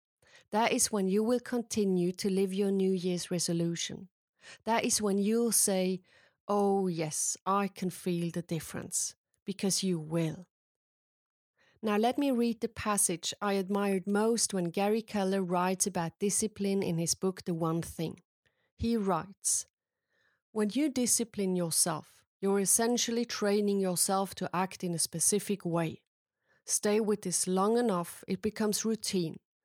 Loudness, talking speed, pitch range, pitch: -31 LUFS, 145 wpm, 180-215 Hz, 195 Hz